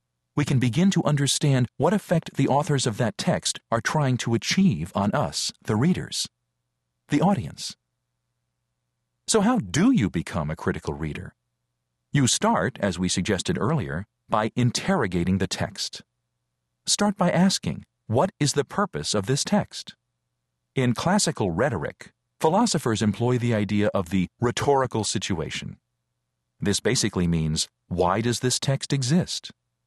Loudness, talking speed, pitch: -24 LUFS, 140 wpm, 105 Hz